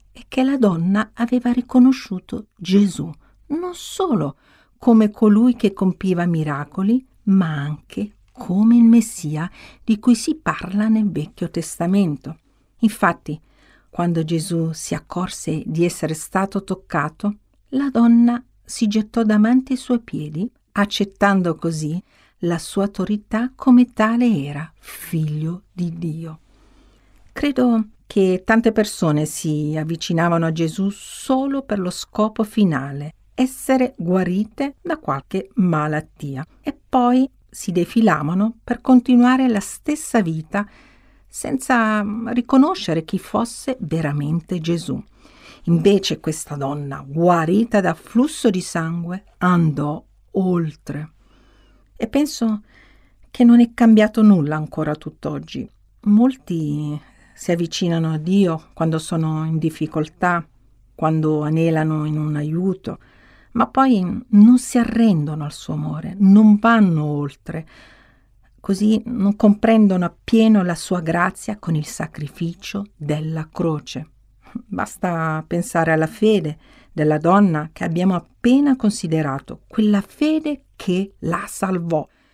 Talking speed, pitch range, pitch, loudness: 115 wpm, 160-225 Hz, 185 Hz, -19 LUFS